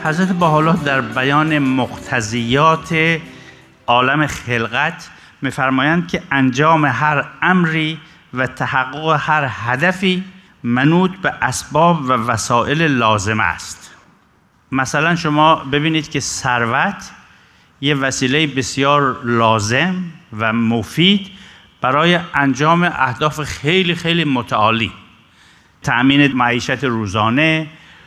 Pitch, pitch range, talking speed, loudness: 145 Hz, 125-160 Hz, 90 wpm, -16 LUFS